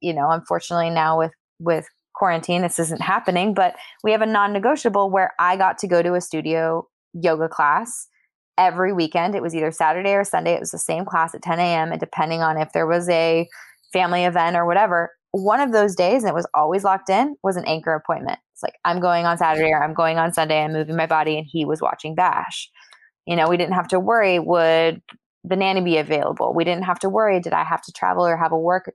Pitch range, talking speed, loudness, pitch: 160-185 Hz, 235 wpm, -20 LUFS, 170 Hz